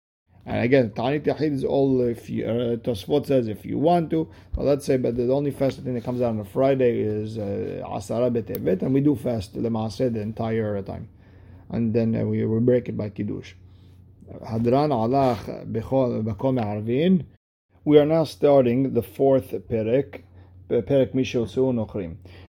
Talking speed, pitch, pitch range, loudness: 150 wpm, 120 Hz, 105-135 Hz, -23 LUFS